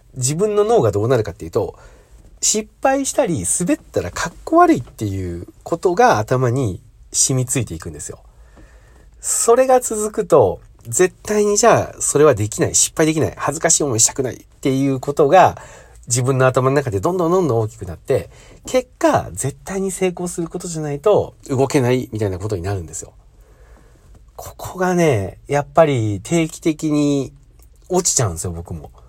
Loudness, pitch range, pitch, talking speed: -17 LUFS, 105-175 Hz, 135 Hz, 350 characters per minute